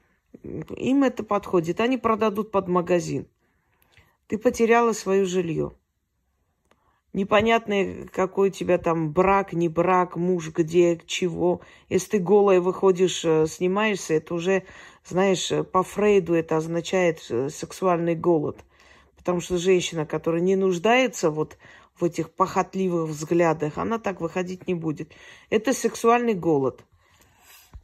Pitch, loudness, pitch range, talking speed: 180 Hz, -23 LUFS, 165-195 Hz, 120 wpm